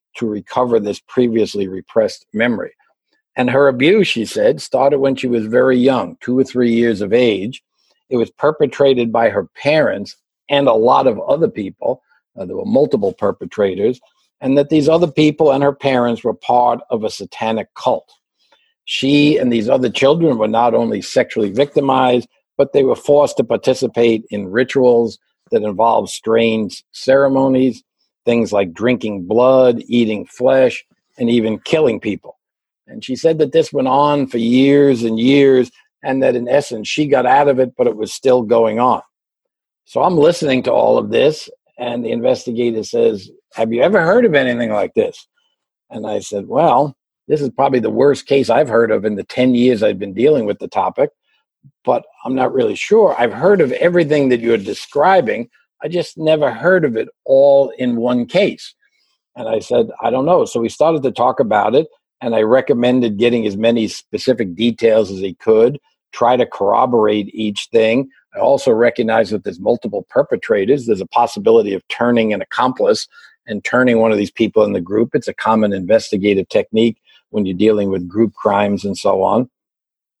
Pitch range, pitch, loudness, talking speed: 115-140 Hz, 125 Hz, -15 LUFS, 180 wpm